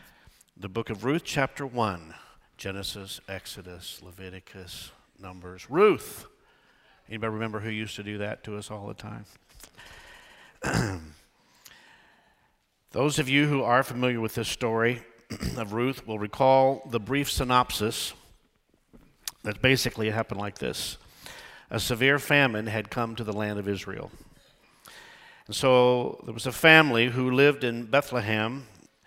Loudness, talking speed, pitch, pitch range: -26 LUFS, 130 wpm, 115 Hz, 105-130 Hz